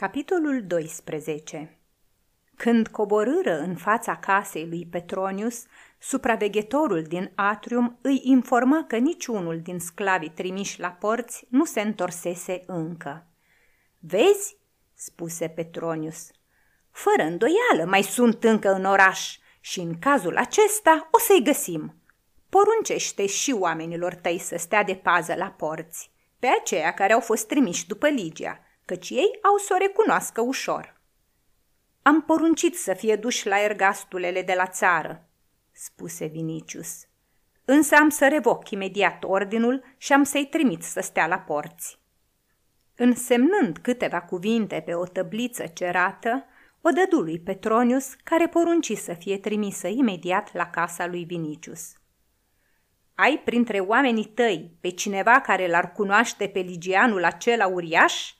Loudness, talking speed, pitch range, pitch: -23 LUFS, 130 wpm, 180-265 Hz, 205 Hz